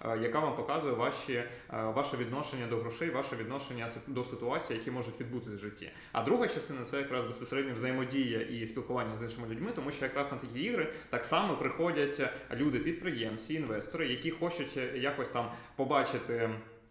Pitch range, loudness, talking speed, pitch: 115-140 Hz, -35 LUFS, 165 wpm, 125 Hz